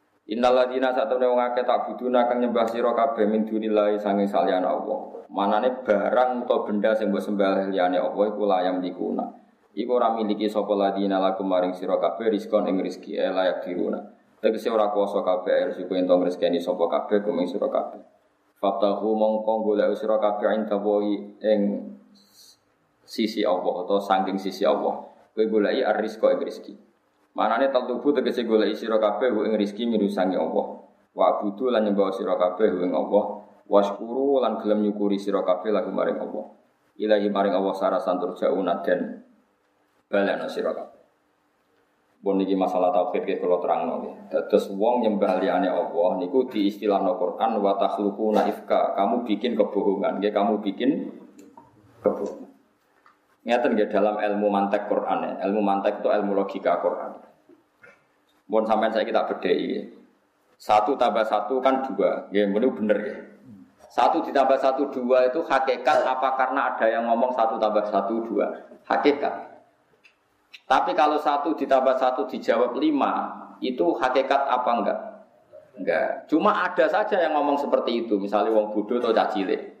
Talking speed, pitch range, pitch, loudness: 150 wpm, 100-125 Hz, 105 Hz, -24 LUFS